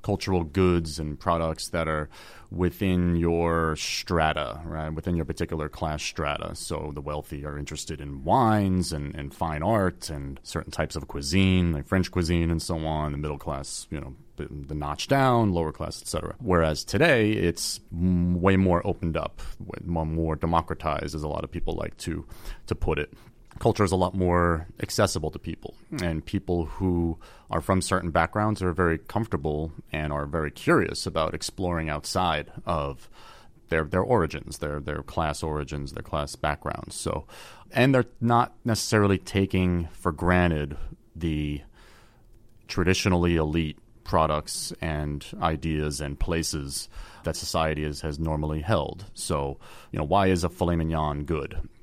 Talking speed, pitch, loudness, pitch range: 155 wpm, 85 Hz, -27 LUFS, 75-90 Hz